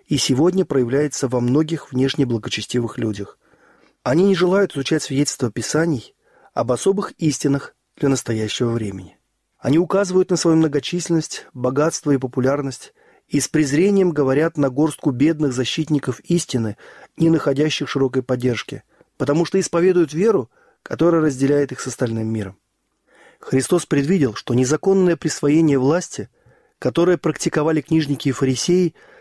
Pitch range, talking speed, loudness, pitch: 130-165 Hz, 125 wpm, -19 LUFS, 145 Hz